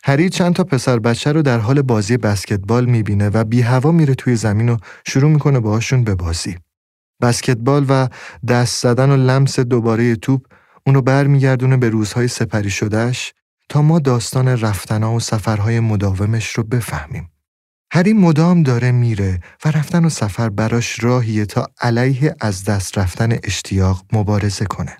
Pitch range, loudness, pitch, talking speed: 110-135 Hz, -16 LUFS, 120 Hz, 155 wpm